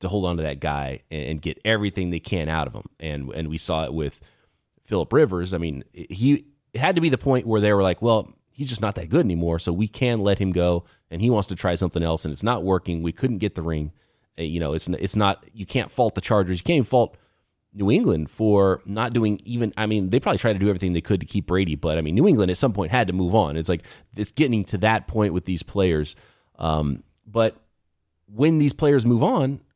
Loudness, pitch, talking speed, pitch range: -23 LUFS, 95 Hz, 255 wpm, 85-110 Hz